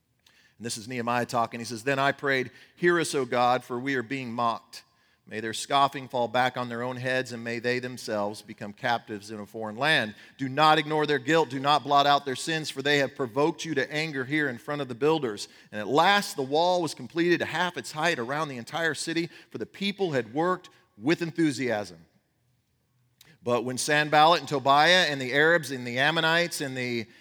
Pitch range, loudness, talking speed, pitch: 120-155 Hz, -26 LUFS, 215 wpm, 135 Hz